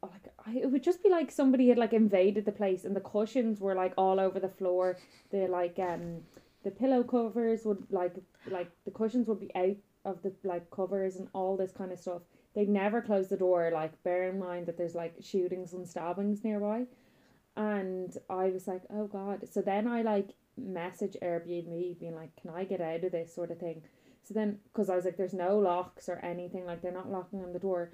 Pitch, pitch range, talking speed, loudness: 190 Hz, 180-210 Hz, 220 wpm, -33 LUFS